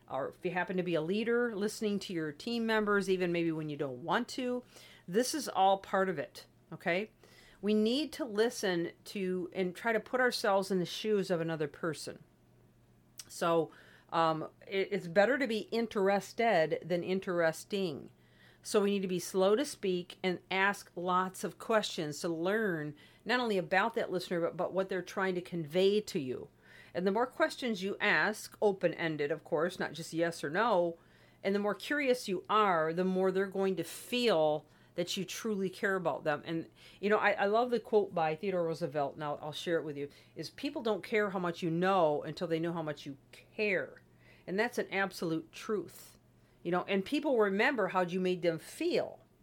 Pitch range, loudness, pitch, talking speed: 165-210 Hz, -33 LUFS, 190 Hz, 195 wpm